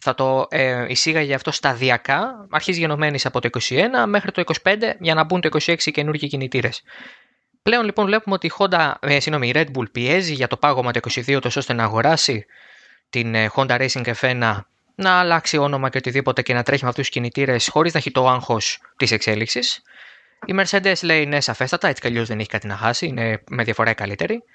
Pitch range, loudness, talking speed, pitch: 120-160 Hz, -19 LUFS, 205 wpm, 135 Hz